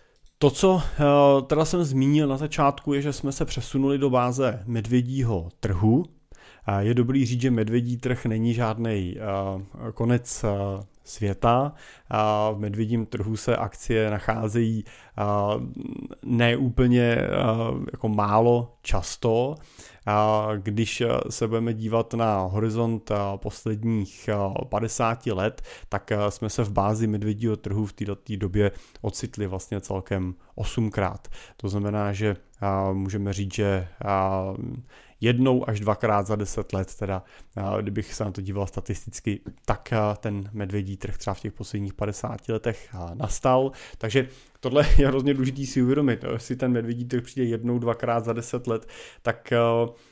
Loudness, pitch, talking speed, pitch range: -25 LUFS, 110 Hz, 130 wpm, 105-125 Hz